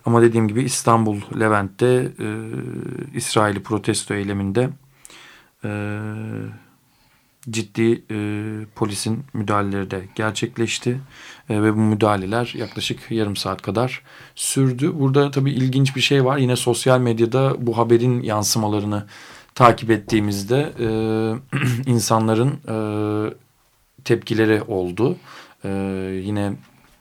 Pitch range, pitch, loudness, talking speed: 105-125 Hz, 115 Hz, -20 LUFS, 100 wpm